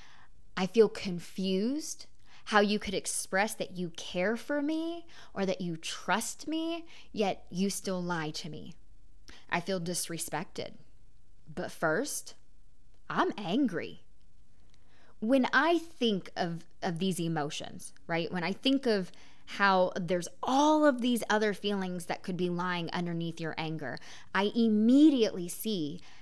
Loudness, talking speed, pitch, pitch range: -31 LUFS, 135 wpm, 190 Hz, 175-230 Hz